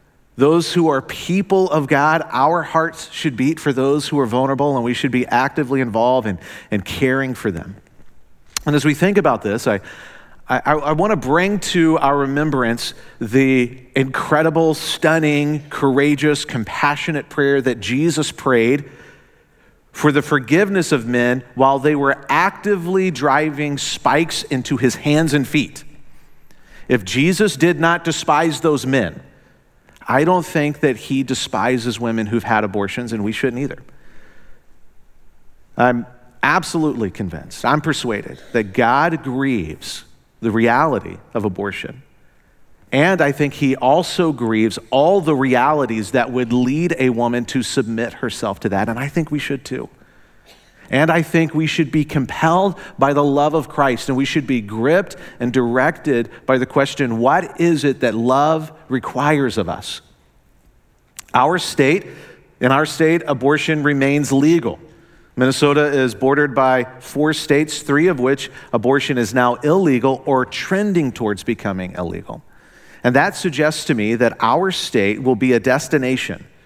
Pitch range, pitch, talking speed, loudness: 125-155 Hz, 140 Hz, 150 wpm, -17 LUFS